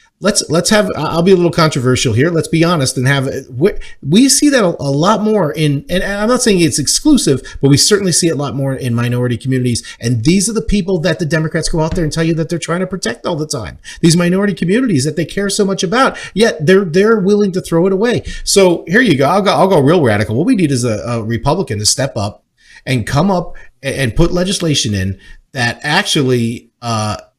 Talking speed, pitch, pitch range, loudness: 235 wpm, 165 Hz, 135-195 Hz, -13 LUFS